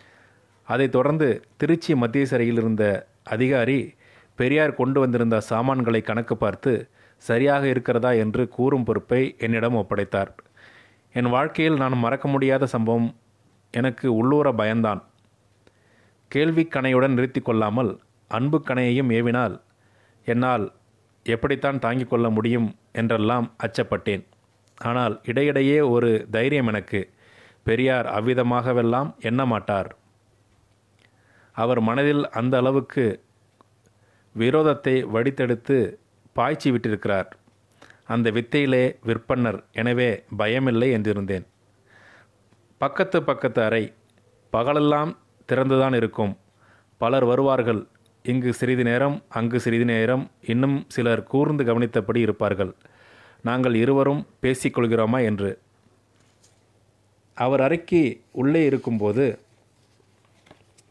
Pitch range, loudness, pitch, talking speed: 110-130 Hz, -22 LUFS, 120 Hz, 90 wpm